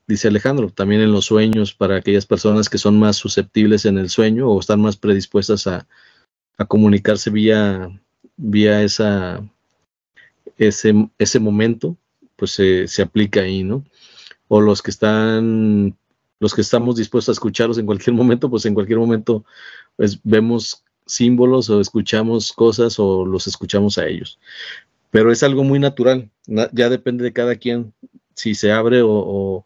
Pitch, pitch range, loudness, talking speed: 110 Hz, 105-115 Hz, -16 LUFS, 160 wpm